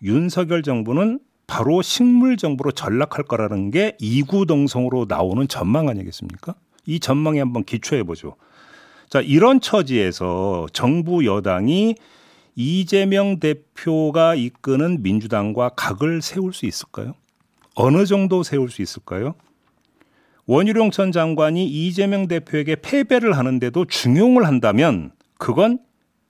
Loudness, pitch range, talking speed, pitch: -19 LUFS, 125-195 Hz, 280 characters per minute, 155 Hz